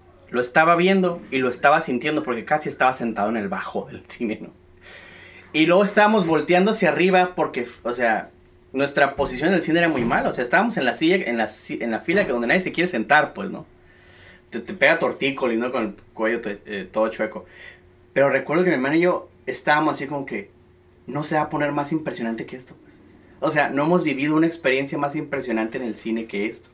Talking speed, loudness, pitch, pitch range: 225 wpm, -21 LUFS, 145 Hz, 120-165 Hz